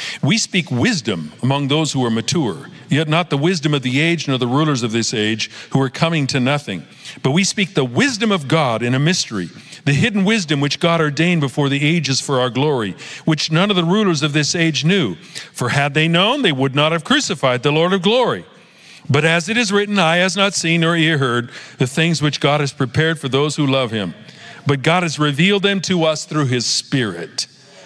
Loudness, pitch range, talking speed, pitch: -17 LUFS, 135-175 Hz, 220 wpm, 155 Hz